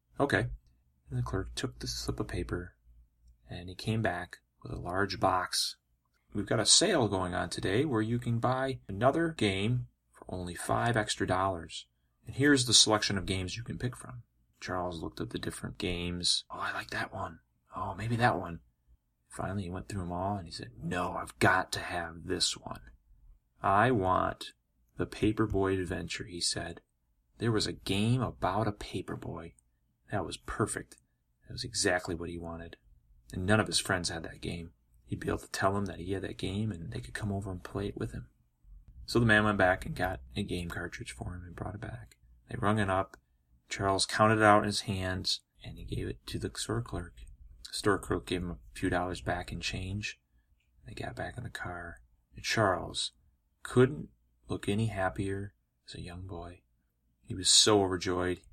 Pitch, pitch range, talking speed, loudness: 90 Hz, 65-105 Hz, 200 wpm, -31 LUFS